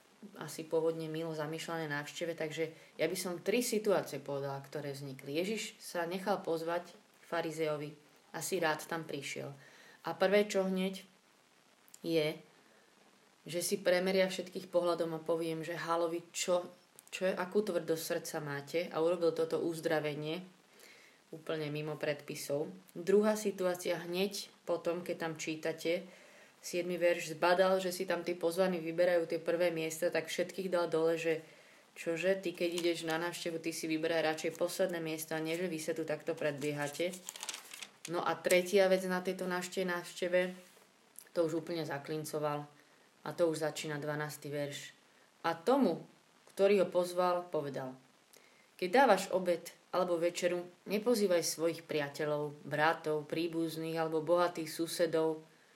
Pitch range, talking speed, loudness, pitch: 160-180 Hz, 140 wpm, -35 LUFS, 170 Hz